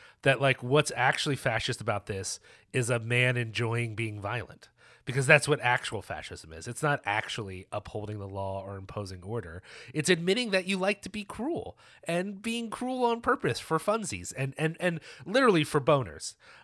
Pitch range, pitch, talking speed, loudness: 105-160 Hz, 130 Hz, 175 wpm, -29 LUFS